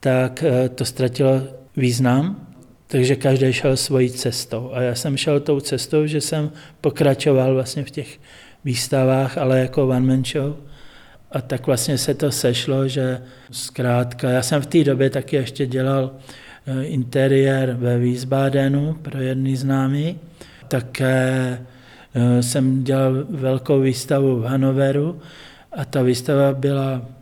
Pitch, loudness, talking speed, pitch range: 135 Hz, -20 LUFS, 130 wpm, 130-140 Hz